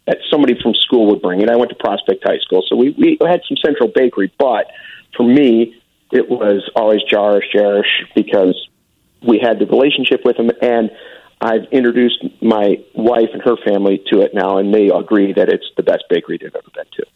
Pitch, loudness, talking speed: 120 Hz, -14 LUFS, 205 wpm